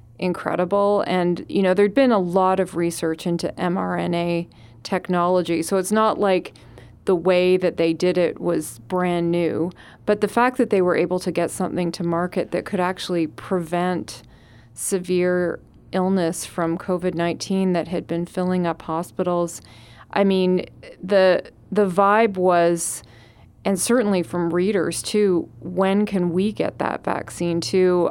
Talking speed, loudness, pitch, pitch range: 150 wpm, -21 LUFS, 180 Hz, 170-190 Hz